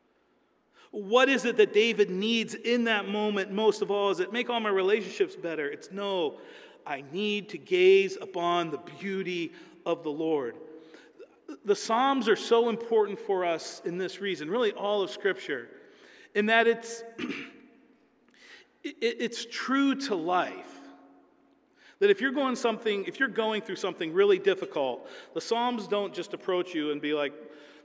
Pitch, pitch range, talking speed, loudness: 225 Hz, 195-270 Hz, 155 wpm, -28 LUFS